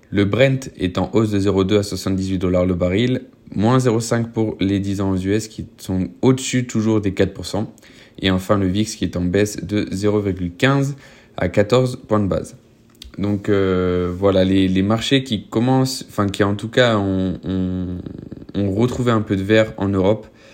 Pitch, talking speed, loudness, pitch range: 100 Hz, 185 wpm, -19 LUFS, 95-110 Hz